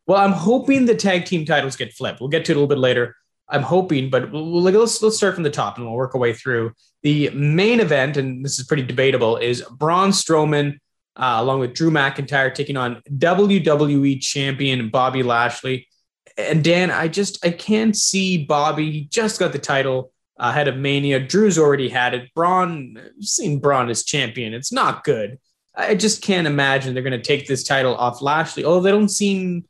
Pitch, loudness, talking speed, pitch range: 145 Hz, -19 LUFS, 200 wpm, 130-180 Hz